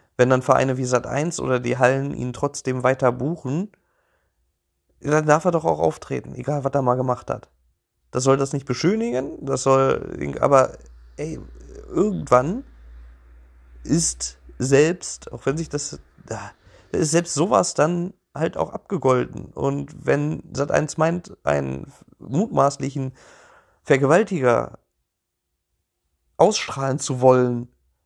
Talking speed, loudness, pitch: 125 wpm, -22 LUFS, 130 Hz